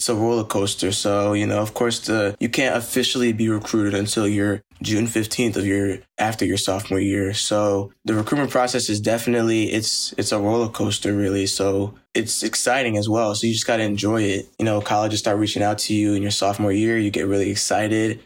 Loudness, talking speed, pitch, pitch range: -21 LUFS, 215 wpm, 105 Hz, 100-110 Hz